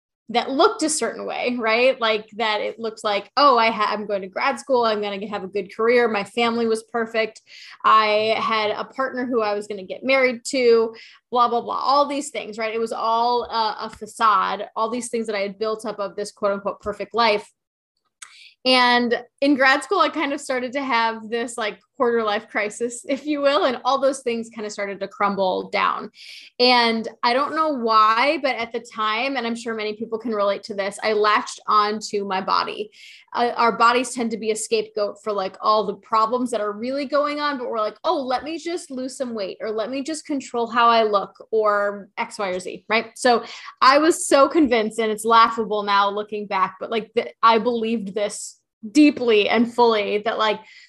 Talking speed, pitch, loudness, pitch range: 215 wpm, 230 Hz, -21 LUFS, 210-255 Hz